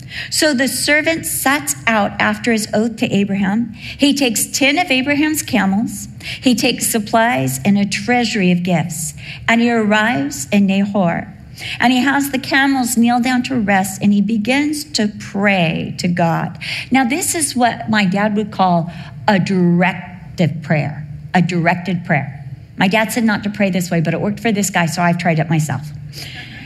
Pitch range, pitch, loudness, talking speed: 170-235 Hz, 200 Hz, -16 LUFS, 175 wpm